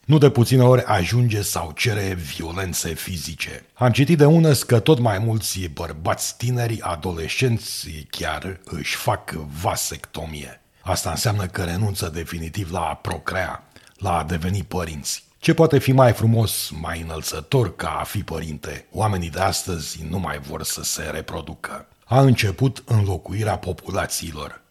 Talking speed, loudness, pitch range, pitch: 145 wpm, -21 LUFS, 80-115 Hz, 95 Hz